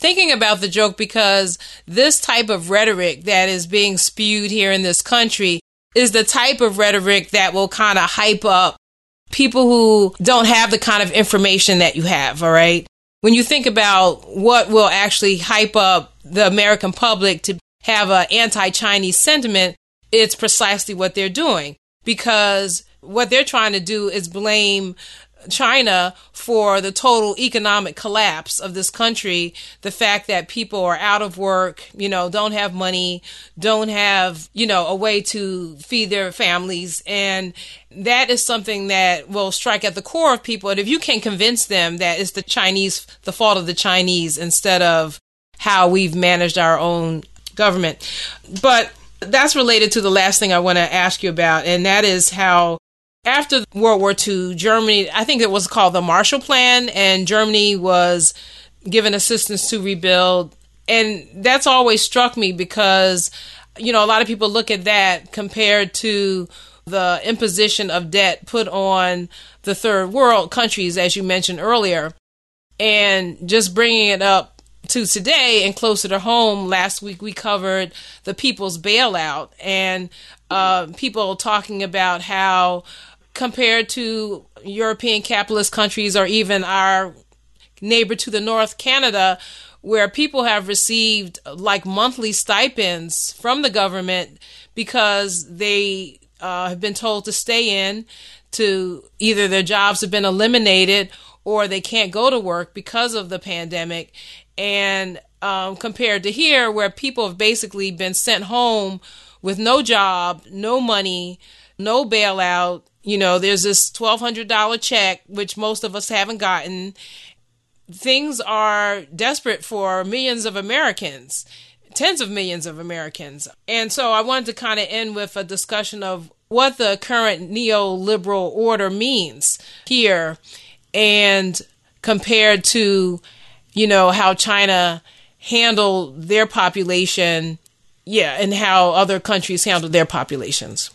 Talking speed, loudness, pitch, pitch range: 155 wpm, -16 LUFS, 200 Hz, 185-220 Hz